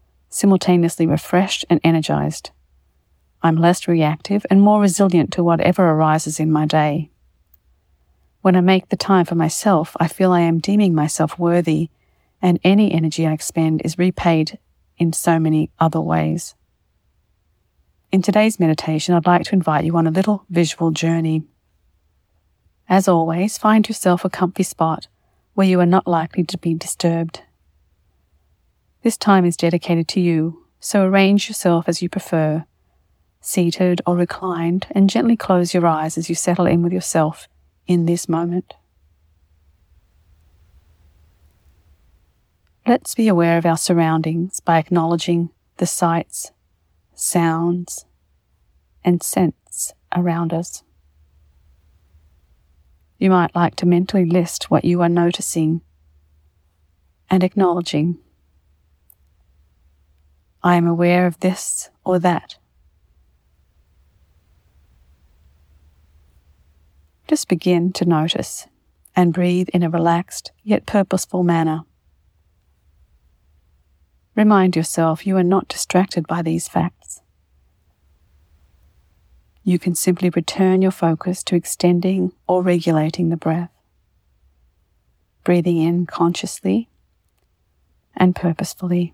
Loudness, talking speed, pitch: -18 LUFS, 115 wpm, 160 Hz